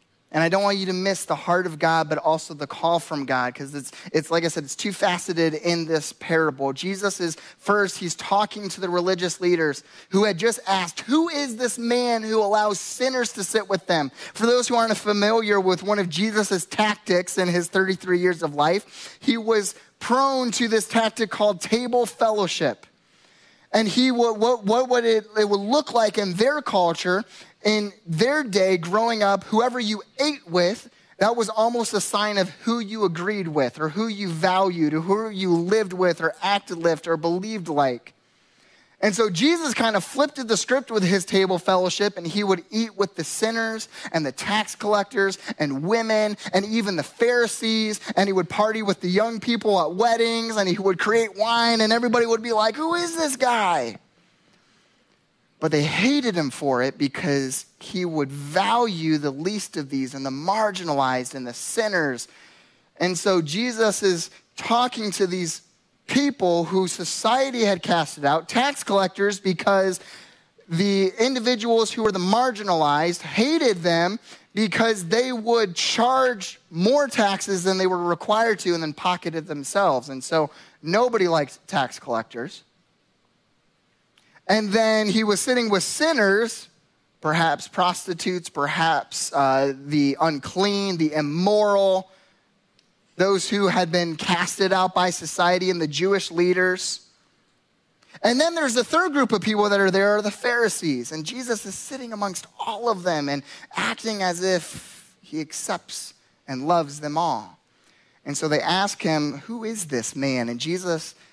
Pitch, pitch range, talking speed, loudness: 195 Hz, 170-220 Hz, 170 wpm, -22 LUFS